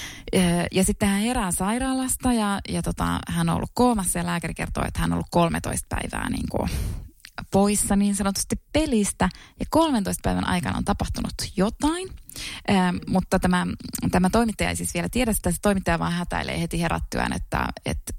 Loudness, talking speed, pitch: -24 LUFS, 170 wpm, 180 Hz